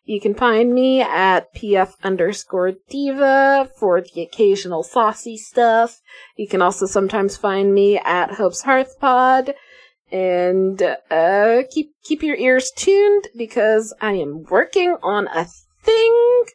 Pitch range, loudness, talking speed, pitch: 195-265 Hz, -17 LUFS, 135 wpm, 220 Hz